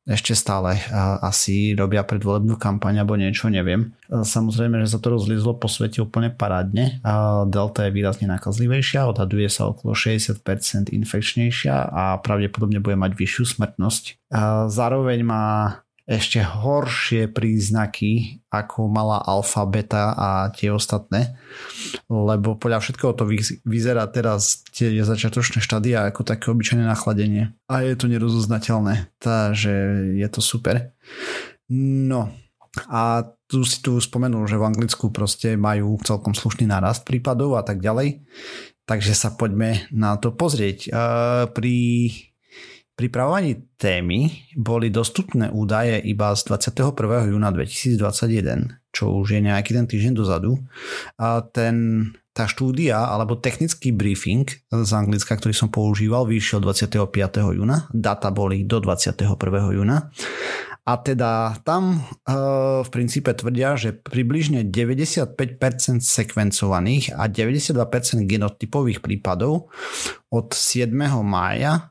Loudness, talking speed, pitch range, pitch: -21 LUFS, 120 wpm, 105-120 Hz, 115 Hz